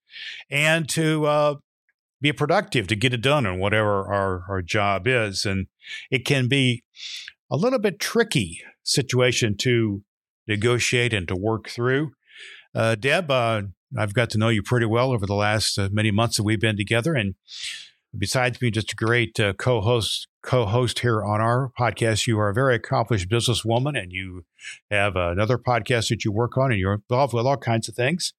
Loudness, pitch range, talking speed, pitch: -22 LUFS, 105-130 Hz, 185 wpm, 115 Hz